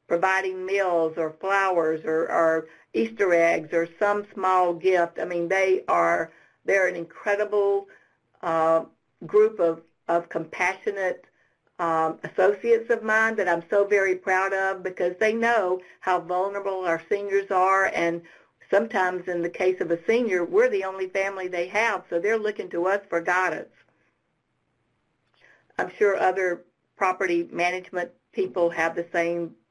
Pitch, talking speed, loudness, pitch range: 185 Hz, 145 wpm, -24 LUFS, 170-200 Hz